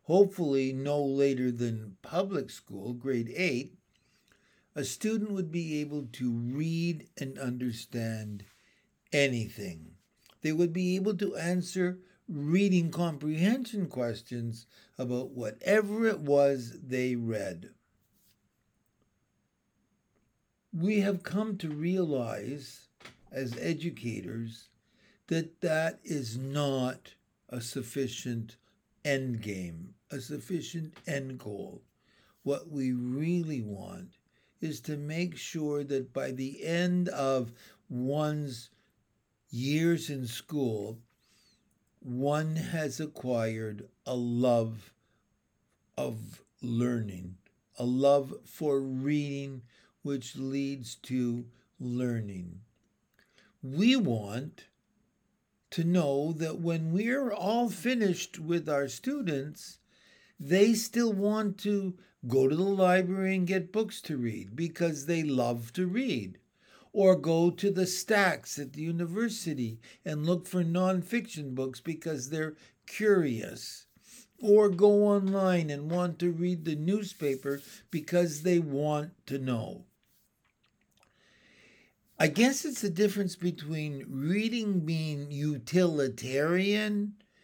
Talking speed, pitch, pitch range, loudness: 105 wpm, 150 Hz, 125-180 Hz, -31 LUFS